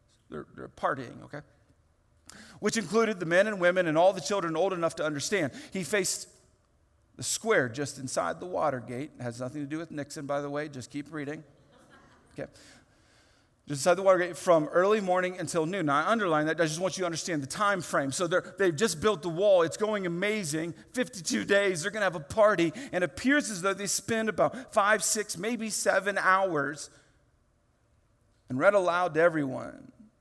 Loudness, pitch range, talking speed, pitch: -28 LUFS, 145-200 Hz, 190 wpm, 170 Hz